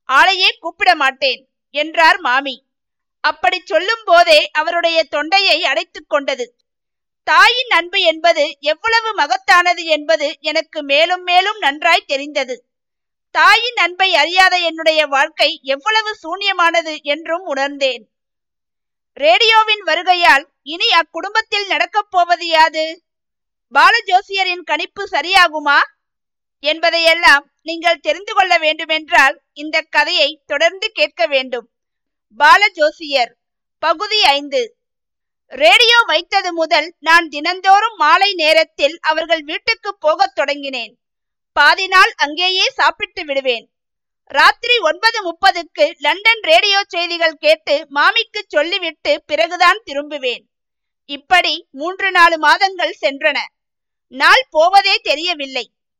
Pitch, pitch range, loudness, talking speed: 330 Hz, 295-375 Hz, -13 LUFS, 90 wpm